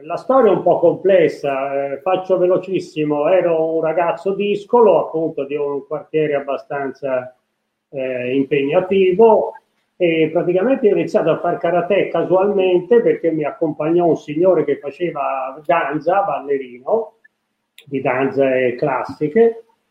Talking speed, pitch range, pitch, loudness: 120 wpm, 140-185 Hz, 165 Hz, -17 LUFS